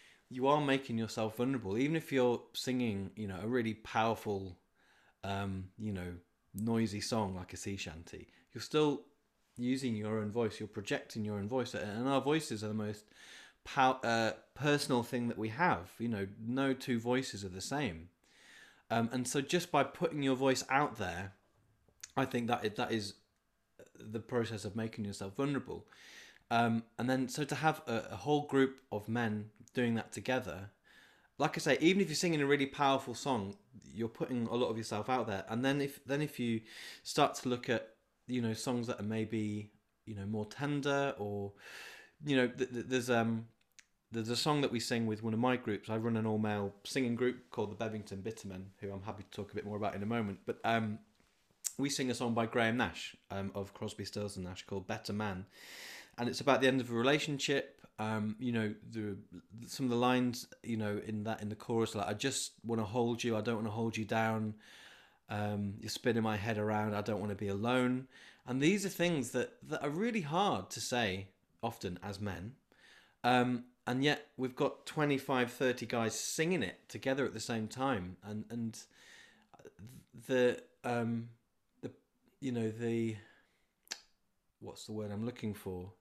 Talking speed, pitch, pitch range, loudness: 195 wpm, 115 Hz, 105-130 Hz, -36 LUFS